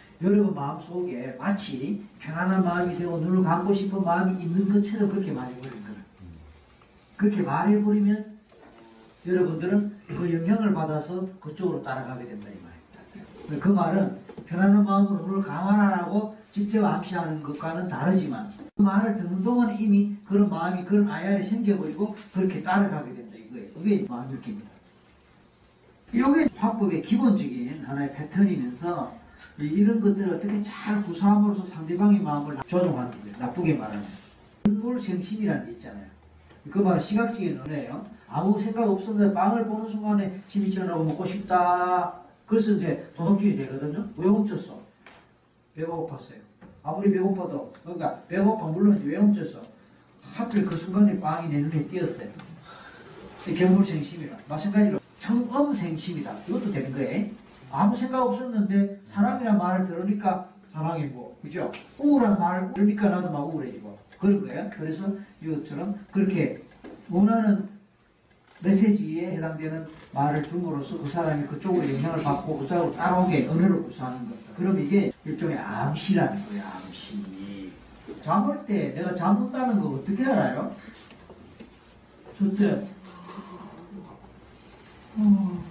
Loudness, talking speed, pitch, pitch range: -26 LUFS, 330 characters per minute, 190 Hz, 165-205 Hz